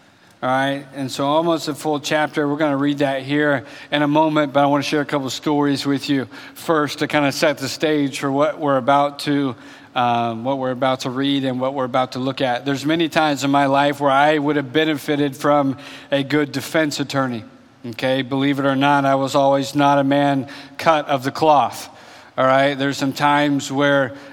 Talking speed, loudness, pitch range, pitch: 220 wpm, -19 LUFS, 135-145 Hz, 140 Hz